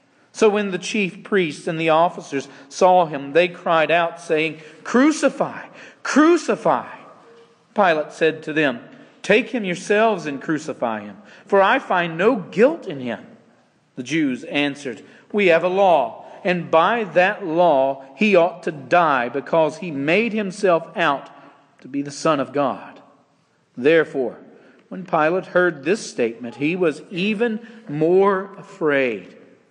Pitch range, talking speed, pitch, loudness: 150-205 Hz, 140 wpm, 175 Hz, -19 LUFS